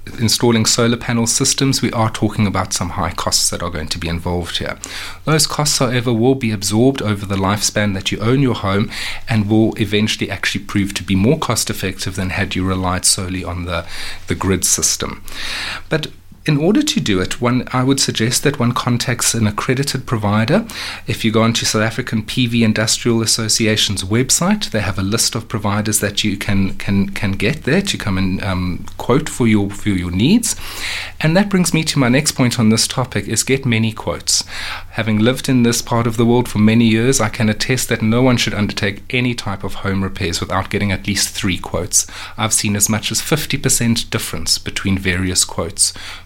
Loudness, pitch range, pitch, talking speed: -16 LUFS, 95-120 Hz, 110 Hz, 200 wpm